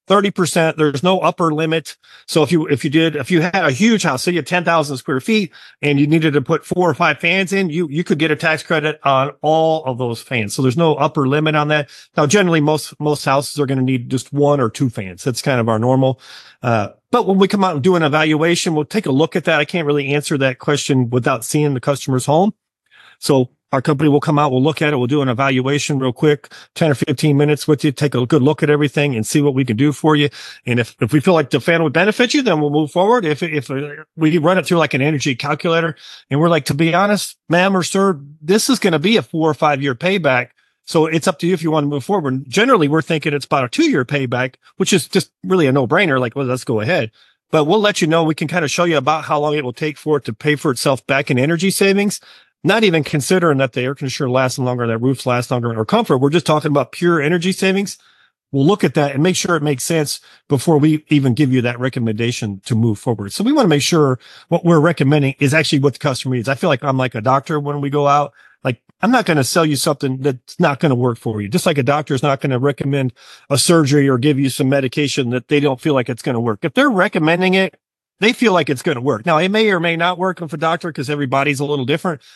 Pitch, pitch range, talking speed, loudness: 150 Hz, 135-170 Hz, 270 wpm, -16 LUFS